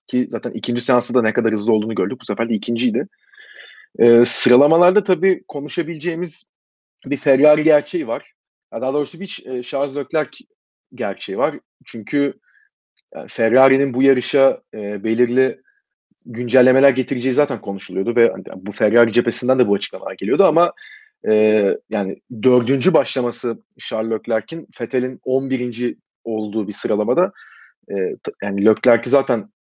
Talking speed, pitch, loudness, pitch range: 135 wpm, 125 Hz, -18 LUFS, 115-140 Hz